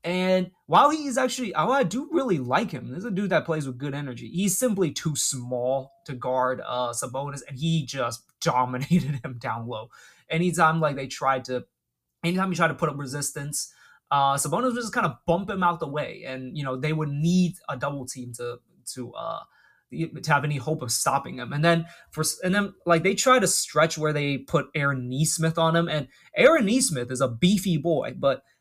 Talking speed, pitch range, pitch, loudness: 210 wpm, 135-175 Hz, 155 Hz, -25 LUFS